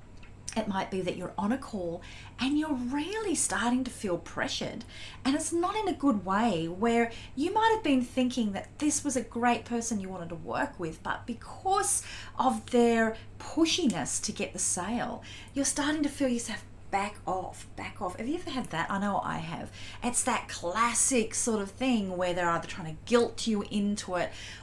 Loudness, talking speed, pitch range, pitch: -30 LUFS, 195 wpm, 190-275 Hz, 235 Hz